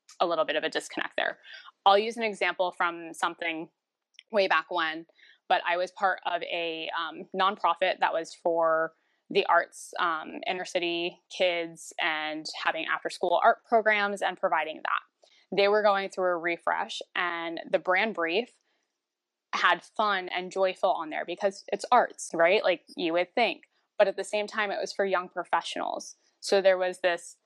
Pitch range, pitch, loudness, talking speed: 170-200 Hz, 185 Hz, -28 LUFS, 175 wpm